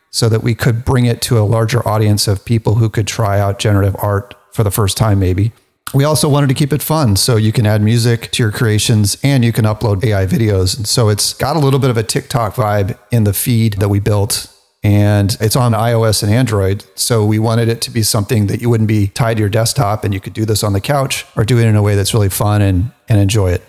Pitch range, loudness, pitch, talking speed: 105-120 Hz, -14 LUFS, 110 Hz, 260 wpm